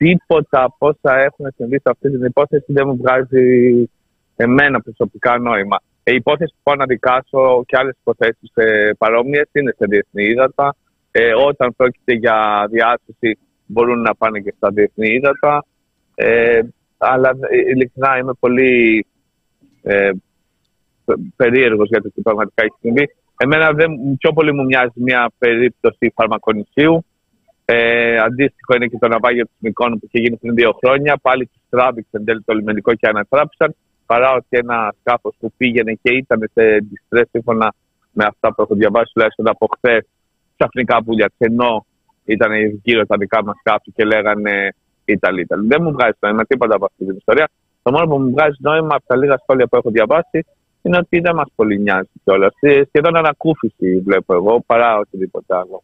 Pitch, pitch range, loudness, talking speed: 120 Hz, 110-140 Hz, -15 LUFS, 160 wpm